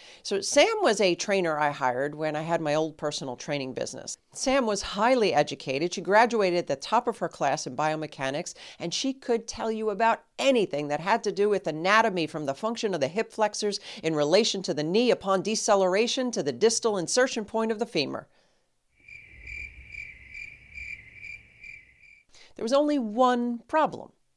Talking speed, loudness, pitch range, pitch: 170 wpm, -26 LUFS, 155-225 Hz, 200 Hz